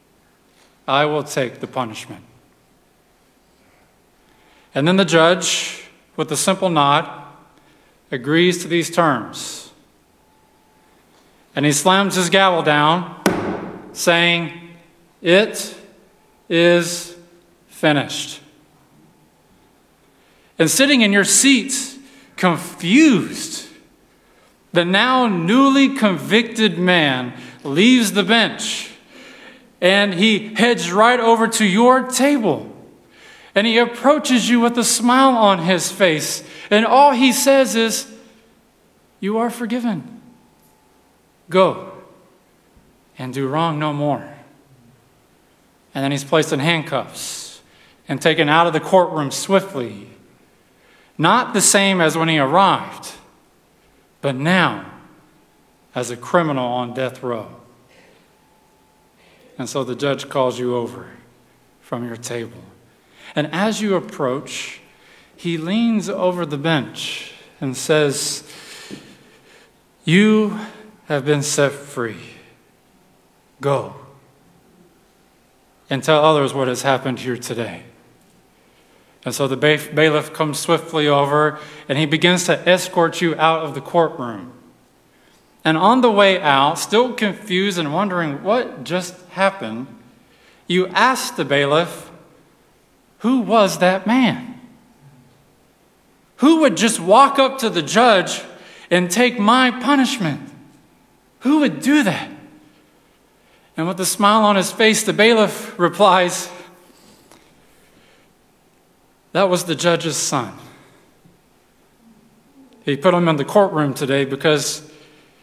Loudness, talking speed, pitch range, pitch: -17 LUFS, 110 wpm, 145-215 Hz, 175 Hz